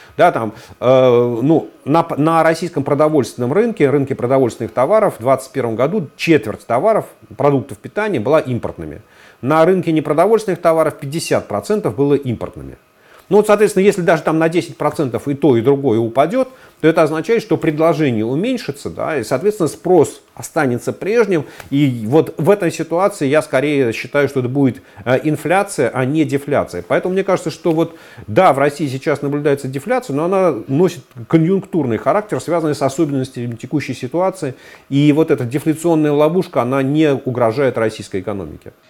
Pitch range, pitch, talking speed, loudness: 130-165 Hz, 150 Hz, 155 wpm, -16 LUFS